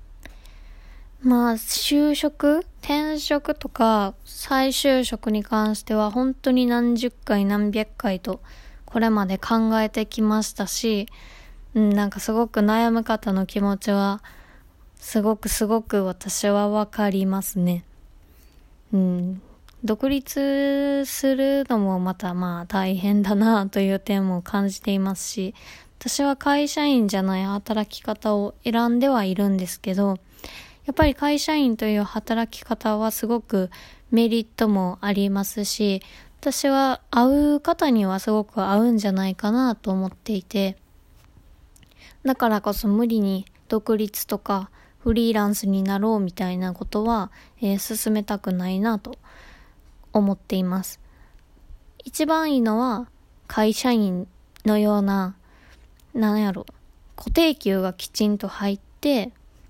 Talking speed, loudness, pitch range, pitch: 245 characters per minute, -23 LUFS, 195-240 Hz, 215 Hz